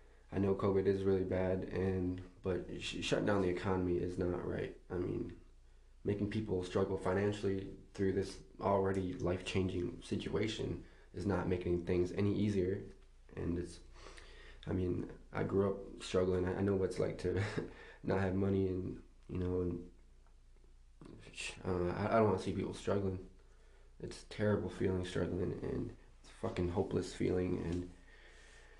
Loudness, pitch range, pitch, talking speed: -37 LUFS, 90-95 Hz, 95 Hz, 155 wpm